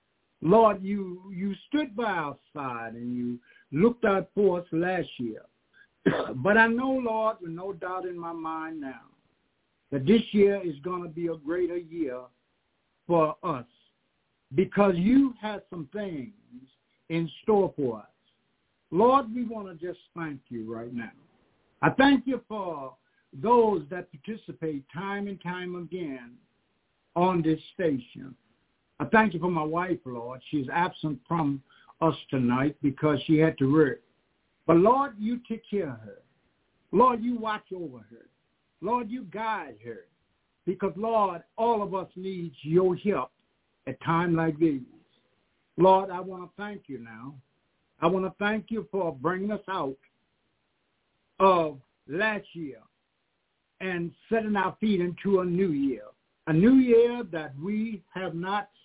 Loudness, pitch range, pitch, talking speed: -27 LUFS, 150-205 Hz, 180 Hz, 150 wpm